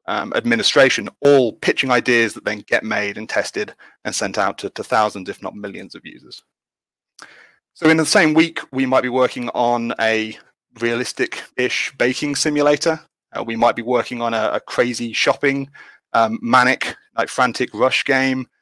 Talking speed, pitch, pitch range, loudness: 170 wpm, 130 Hz, 120-145 Hz, -18 LUFS